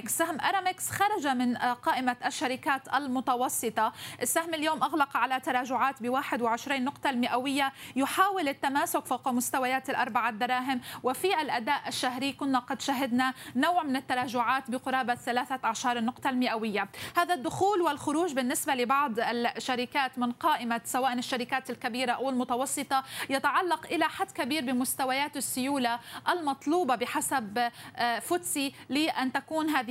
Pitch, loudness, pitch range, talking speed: 265 Hz, -29 LUFS, 250-295 Hz, 120 wpm